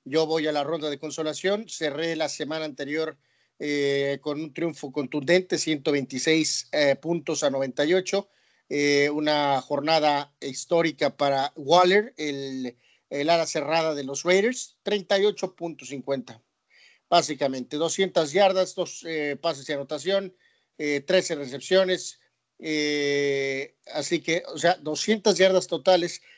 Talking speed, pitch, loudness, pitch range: 125 wpm, 155 Hz, -25 LUFS, 145-175 Hz